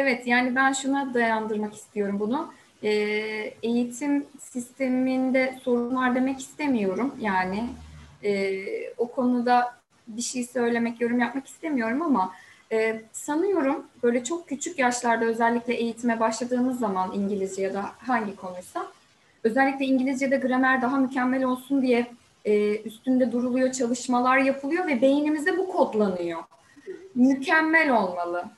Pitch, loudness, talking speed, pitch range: 245 Hz, -25 LUFS, 120 wpm, 220-270 Hz